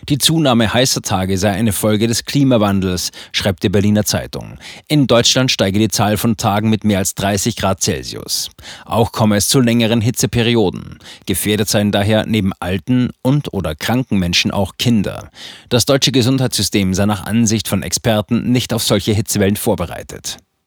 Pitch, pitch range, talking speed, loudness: 110 Hz, 100-120 Hz, 165 wpm, -15 LUFS